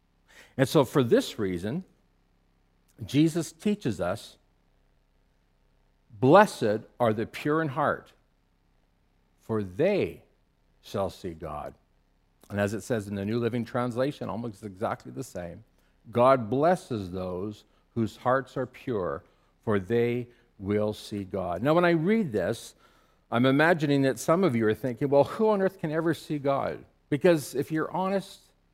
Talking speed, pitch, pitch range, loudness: 145 wpm, 120 Hz, 100-150 Hz, -27 LUFS